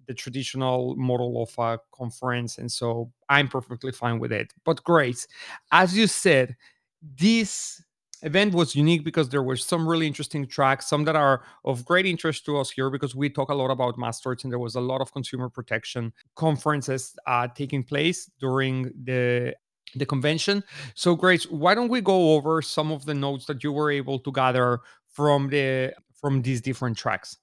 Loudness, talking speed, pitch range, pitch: -24 LUFS, 185 wpm, 125-155 Hz, 135 Hz